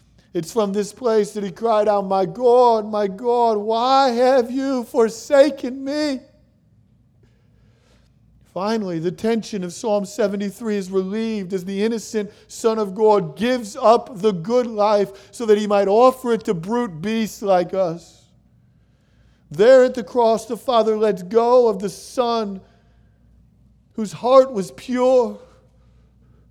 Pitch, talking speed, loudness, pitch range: 215 Hz, 140 wpm, -19 LUFS, 195-240 Hz